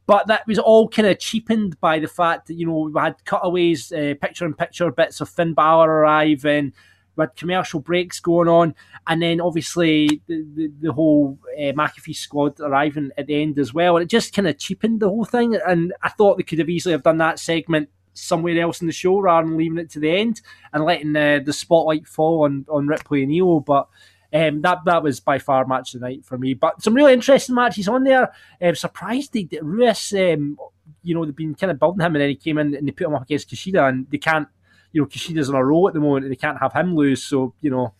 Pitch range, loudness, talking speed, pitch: 145-175 Hz, -19 LUFS, 240 wpm, 160 Hz